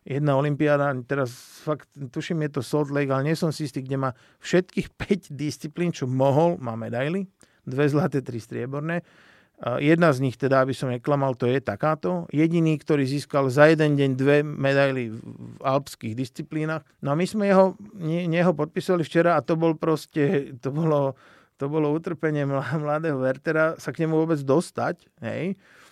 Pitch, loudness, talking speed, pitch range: 150 Hz, -24 LUFS, 170 wpm, 135-165 Hz